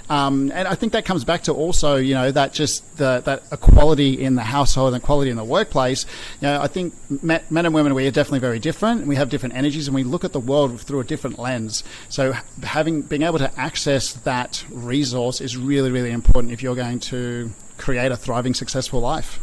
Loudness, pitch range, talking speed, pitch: -21 LUFS, 125-150 Hz, 220 wpm, 135 Hz